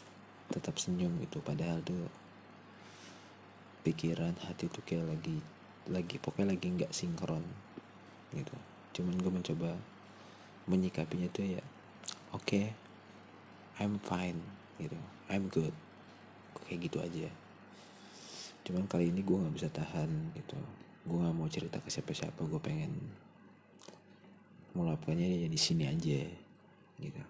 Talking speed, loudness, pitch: 120 wpm, -38 LUFS, 105 Hz